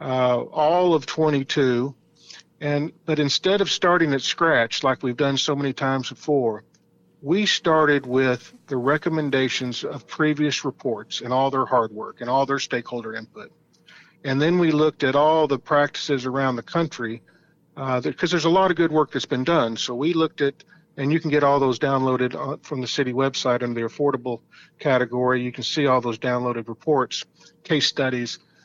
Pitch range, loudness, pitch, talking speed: 130-155 Hz, -22 LUFS, 140 Hz, 180 wpm